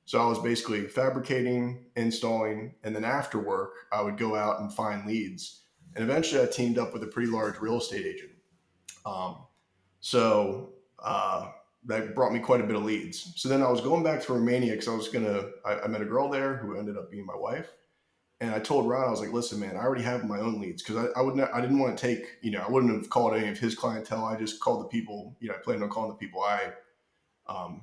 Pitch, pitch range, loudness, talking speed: 115 Hz, 110-130 Hz, -29 LUFS, 245 wpm